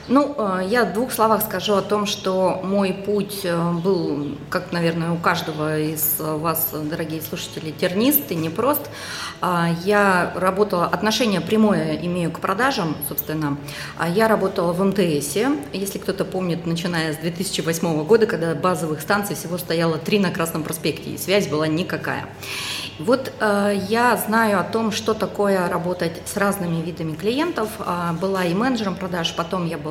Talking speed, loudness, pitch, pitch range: 150 wpm, -21 LUFS, 180 Hz, 165-205 Hz